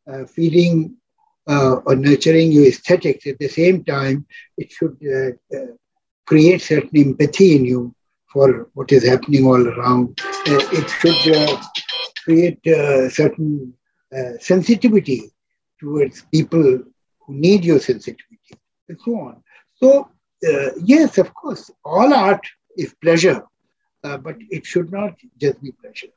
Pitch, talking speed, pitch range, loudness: 160 Hz, 140 wpm, 135-205 Hz, -16 LUFS